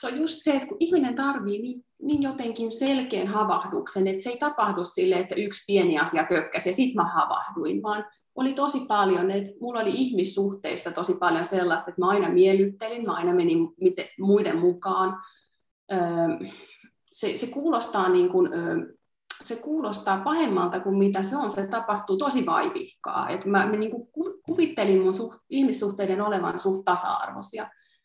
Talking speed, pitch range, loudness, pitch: 155 wpm, 190-285 Hz, -25 LUFS, 215 Hz